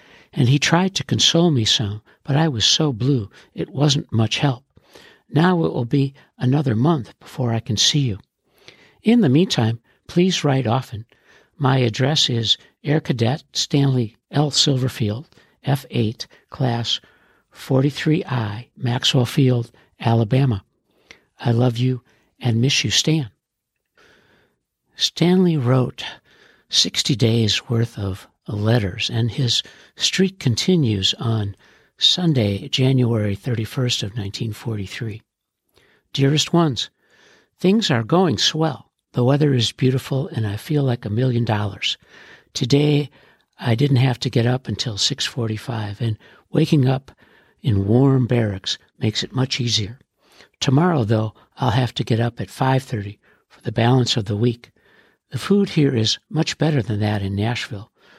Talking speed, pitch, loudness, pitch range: 135 wpm, 125 Hz, -20 LUFS, 115-145 Hz